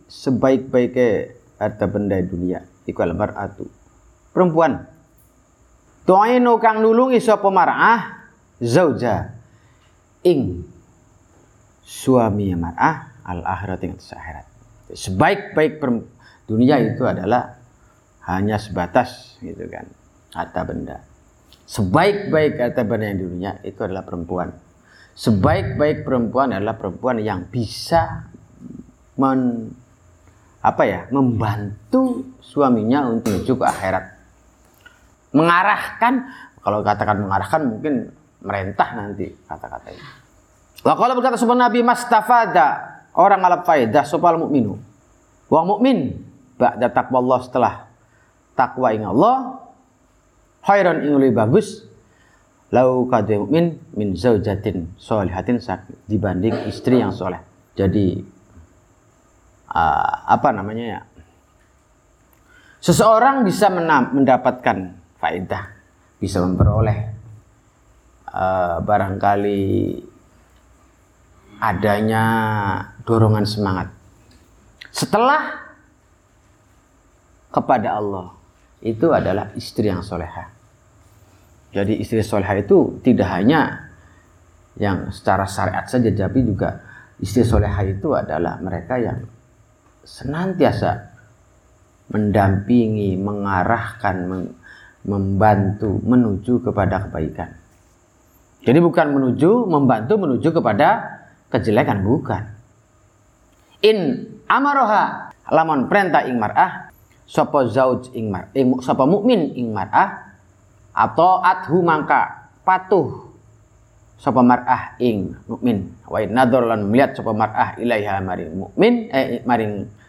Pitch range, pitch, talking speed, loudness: 95-130 Hz, 110 Hz, 90 wpm, -18 LUFS